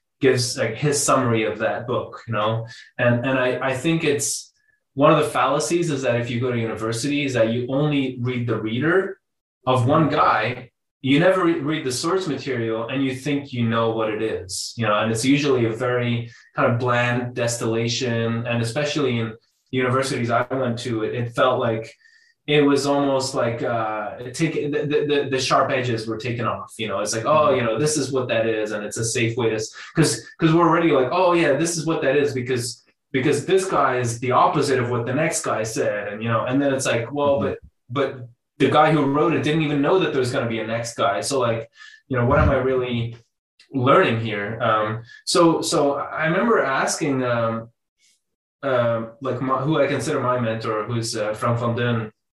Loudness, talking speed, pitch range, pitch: -21 LUFS, 210 wpm, 115-145 Hz, 125 Hz